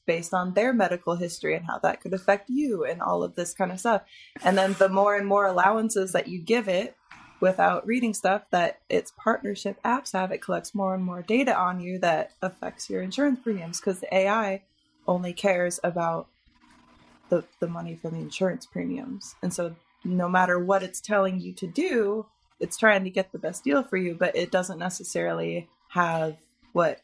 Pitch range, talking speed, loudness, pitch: 175-205 Hz, 195 wpm, -26 LUFS, 190 Hz